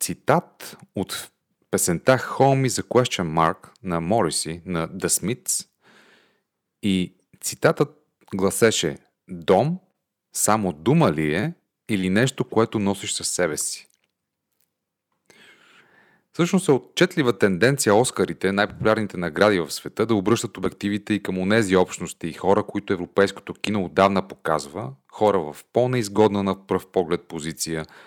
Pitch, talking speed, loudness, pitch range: 100 Hz, 125 wpm, -22 LUFS, 90-120 Hz